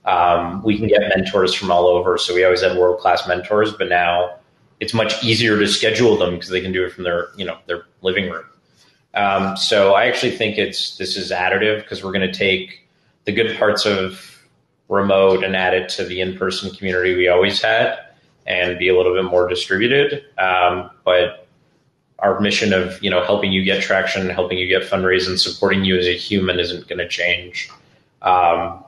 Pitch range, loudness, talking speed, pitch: 90-100 Hz, -17 LUFS, 200 wpm, 95 Hz